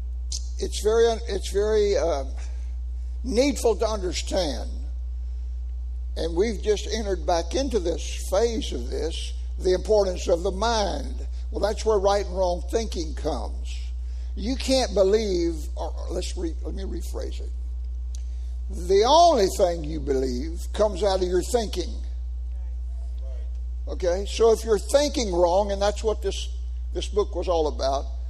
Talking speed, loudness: 140 wpm, -25 LUFS